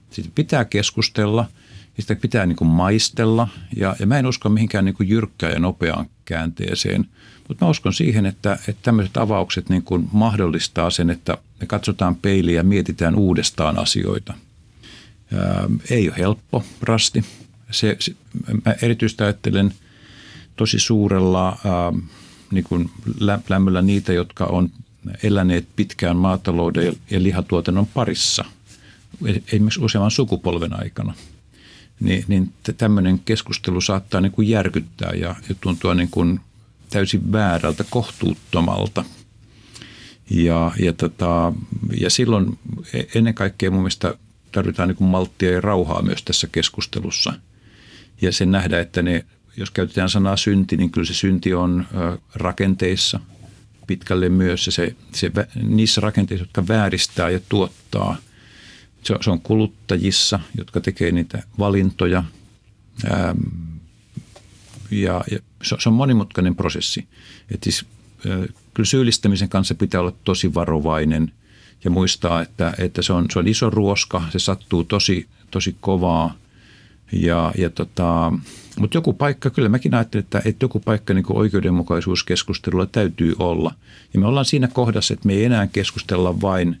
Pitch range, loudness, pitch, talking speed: 90-110 Hz, -20 LUFS, 100 Hz, 135 wpm